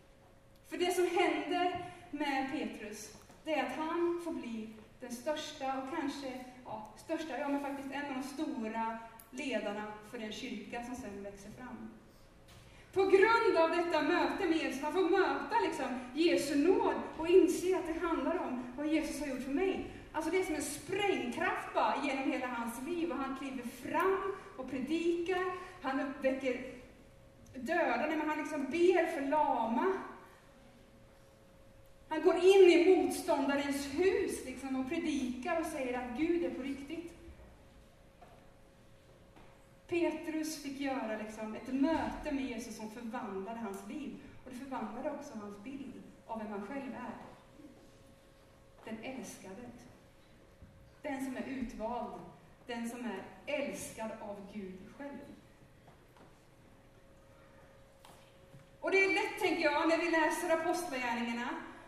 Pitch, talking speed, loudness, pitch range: 285 Hz, 140 wpm, -34 LUFS, 250-330 Hz